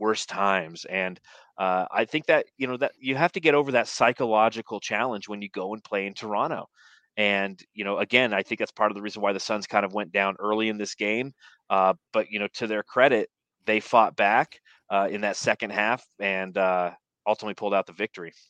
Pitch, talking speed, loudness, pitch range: 105 Hz, 225 wpm, -25 LUFS, 100-110 Hz